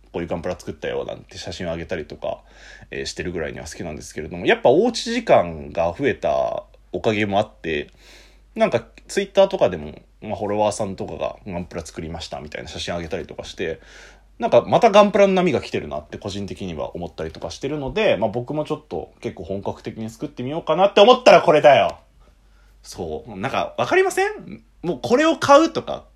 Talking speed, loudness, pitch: 455 characters per minute, -20 LUFS, 130 Hz